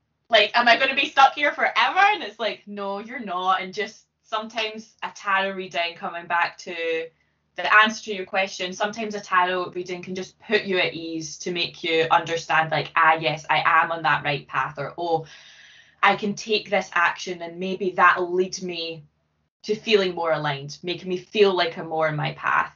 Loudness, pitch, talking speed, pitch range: -22 LUFS, 185 Hz, 205 wpm, 165-210 Hz